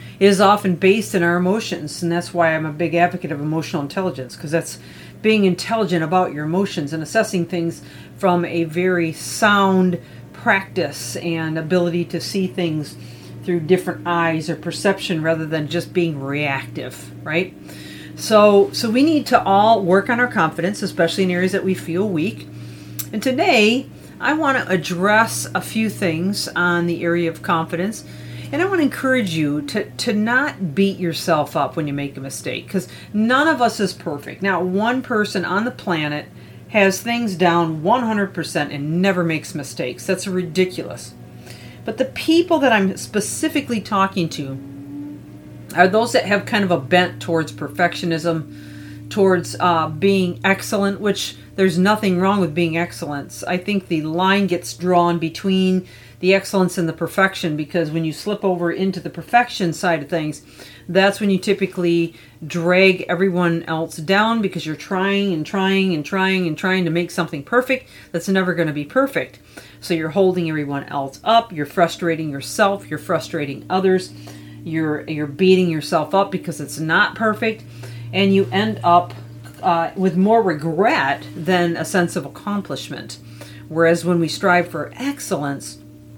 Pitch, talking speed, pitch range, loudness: 175 Hz, 165 wpm, 160-195 Hz, -19 LUFS